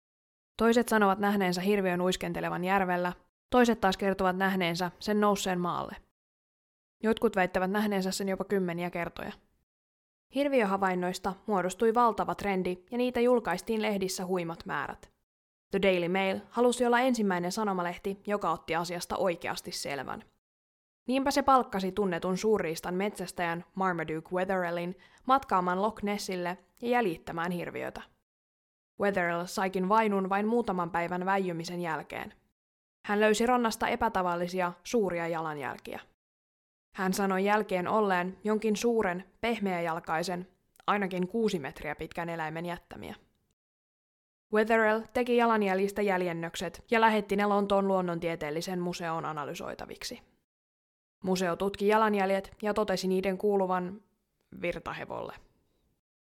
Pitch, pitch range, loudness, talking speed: 190 Hz, 175-210 Hz, -30 LUFS, 110 wpm